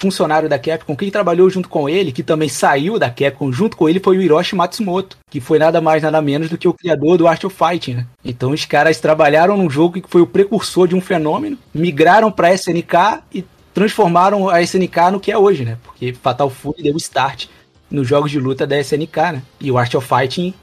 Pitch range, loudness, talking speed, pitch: 145-185 Hz, -15 LUFS, 225 wpm, 165 Hz